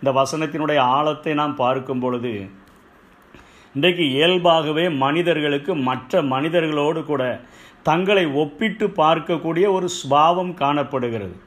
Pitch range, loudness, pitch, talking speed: 135-170 Hz, -20 LUFS, 155 Hz, 95 wpm